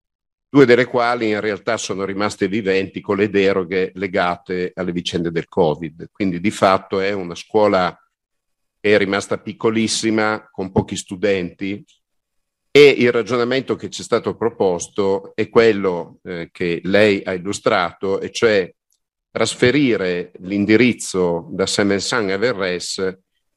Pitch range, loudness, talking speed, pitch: 90-110 Hz, -18 LUFS, 130 wpm, 100 Hz